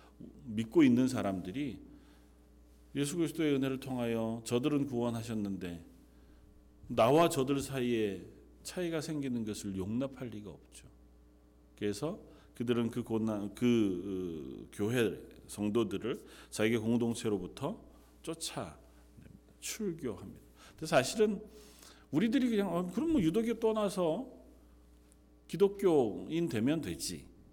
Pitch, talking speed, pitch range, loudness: 115 Hz, 245 characters per minute, 90-150 Hz, -34 LUFS